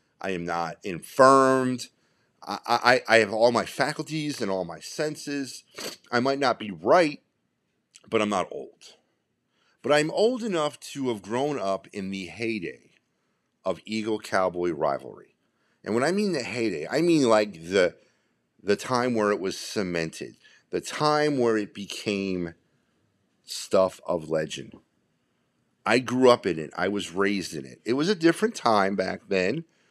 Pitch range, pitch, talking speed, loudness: 95-135 Hz, 115 Hz, 160 wpm, -25 LUFS